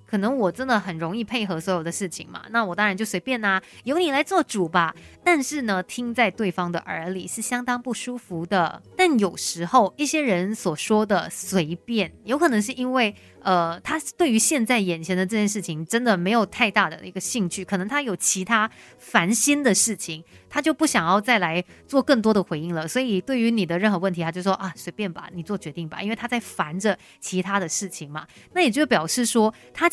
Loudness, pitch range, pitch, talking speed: -23 LUFS, 180-245 Hz, 210 Hz, 315 characters per minute